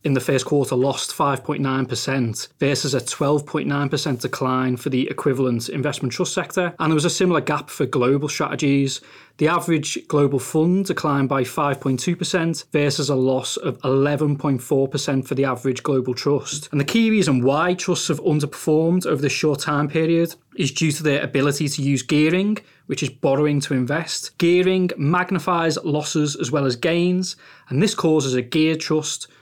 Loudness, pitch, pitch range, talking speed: -21 LUFS, 145 Hz, 135-160 Hz, 165 wpm